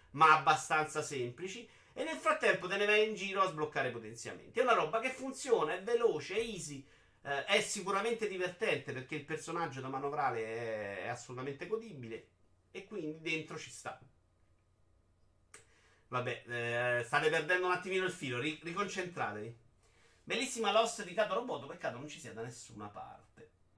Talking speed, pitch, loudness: 155 wpm, 155 Hz, -35 LUFS